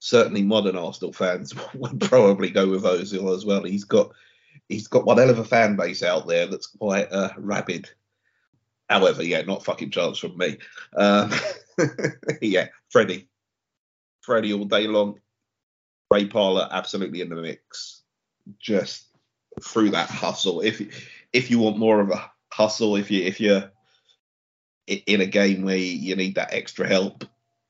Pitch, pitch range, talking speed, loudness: 100 Hz, 95-110 Hz, 155 wpm, -22 LUFS